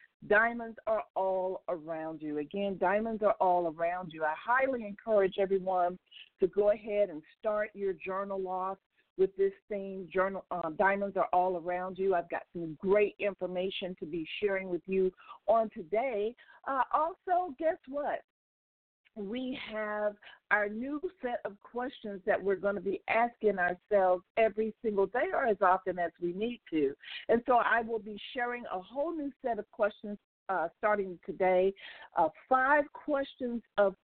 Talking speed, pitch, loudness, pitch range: 160 wpm, 205 Hz, -32 LUFS, 185-240 Hz